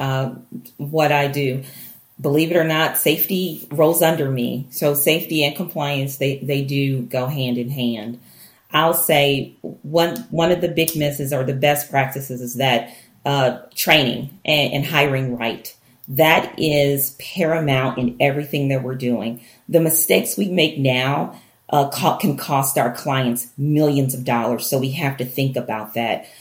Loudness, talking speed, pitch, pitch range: -19 LUFS, 160 wpm, 140 Hz, 130-155 Hz